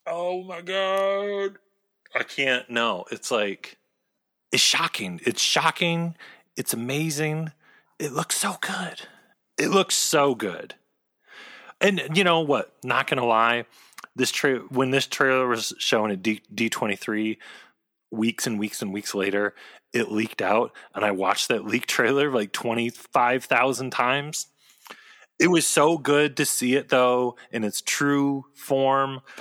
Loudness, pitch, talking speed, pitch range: -24 LUFS, 135 Hz, 145 wpm, 115-165 Hz